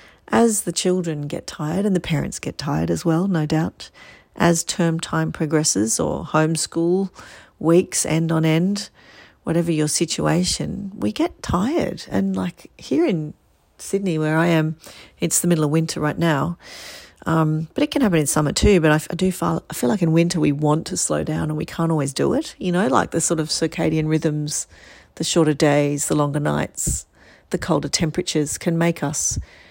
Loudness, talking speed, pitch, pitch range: -21 LUFS, 190 wpm, 160 Hz, 155-175 Hz